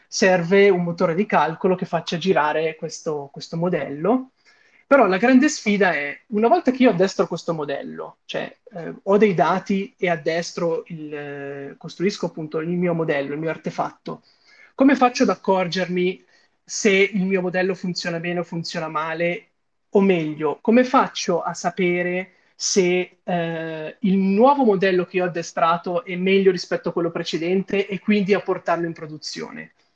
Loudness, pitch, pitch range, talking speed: -21 LUFS, 180 Hz, 170-200 Hz, 160 wpm